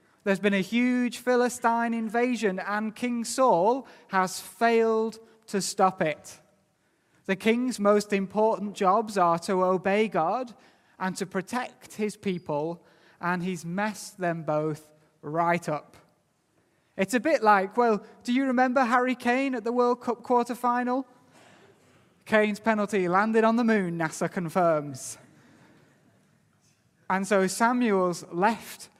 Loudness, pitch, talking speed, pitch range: -26 LUFS, 205 Hz, 130 wpm, 185-235 Hz